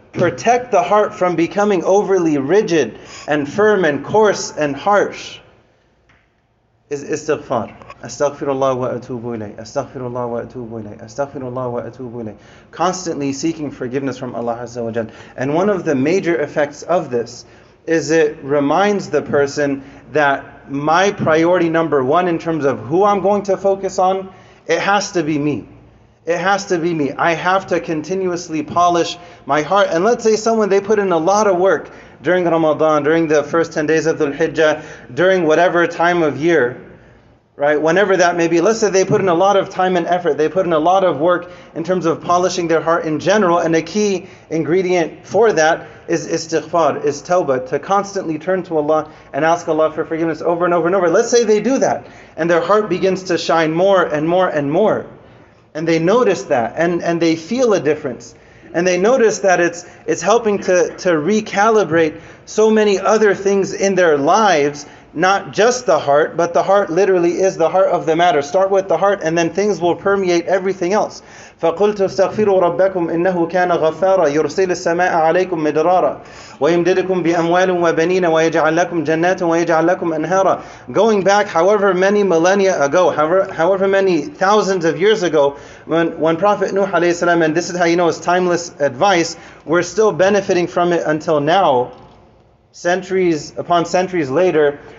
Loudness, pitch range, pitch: -16 LUFS, 150-190 Hz, 170 Hz